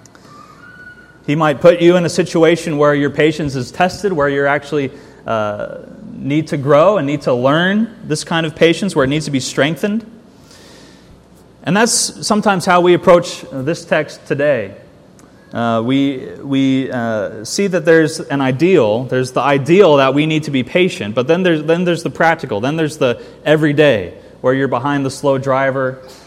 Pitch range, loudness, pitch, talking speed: 135-175 Hz, -14 LUFS, 155 Hz, 175 wpm